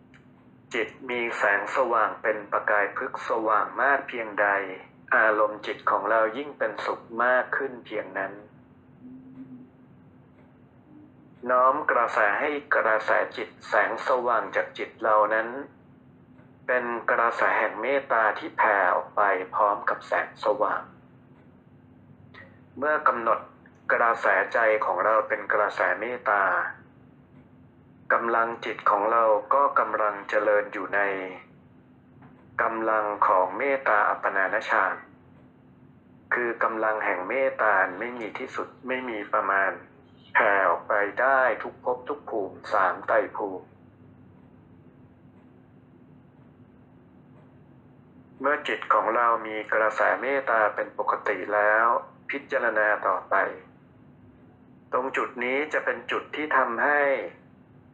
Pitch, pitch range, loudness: 110 Hz, 105-125 Hz, -25 LUFS